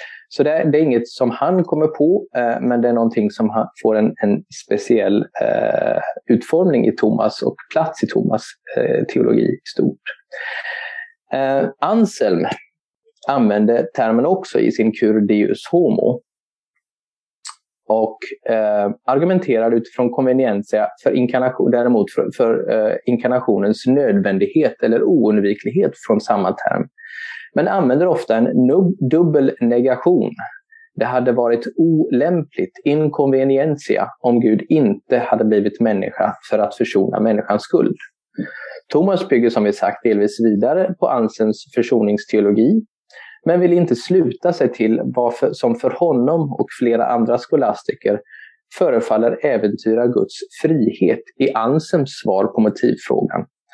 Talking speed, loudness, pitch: 125 wpm, -17 LUFS, 140 Hz